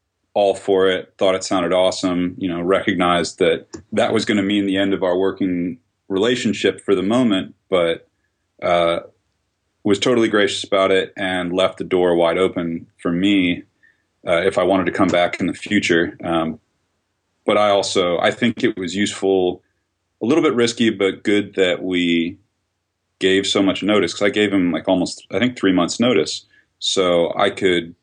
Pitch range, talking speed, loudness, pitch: 90-100 Hz, 180 wpm, -18 LUFS, 95 Hz